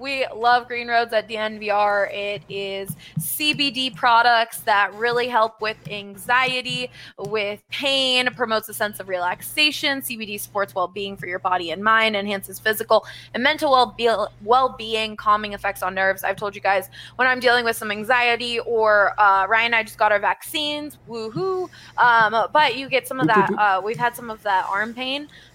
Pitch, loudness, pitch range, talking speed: 220 Hz, -20 LUFS, 200-245 Hz, 175 wpm